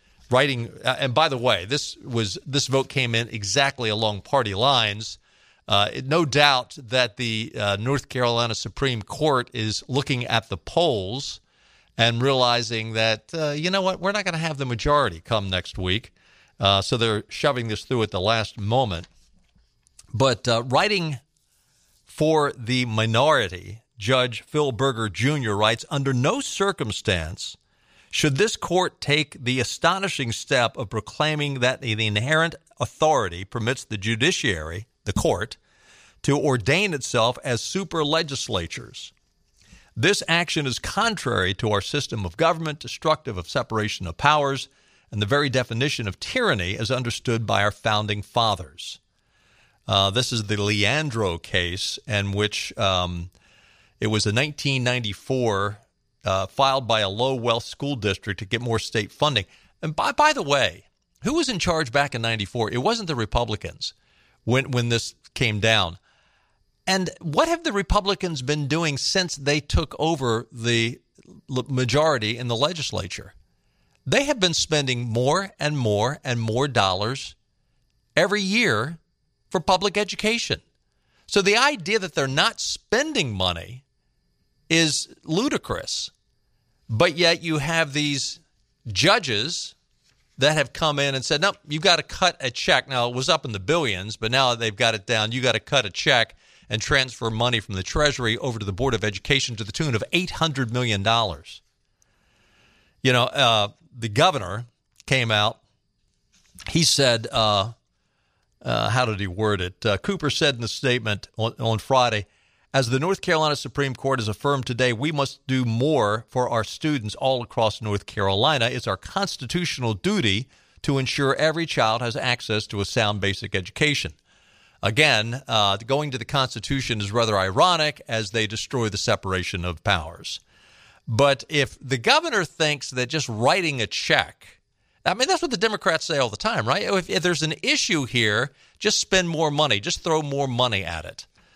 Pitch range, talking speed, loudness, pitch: 110-145 Hz, 160 wpm, -23 LUFS, 125 Hz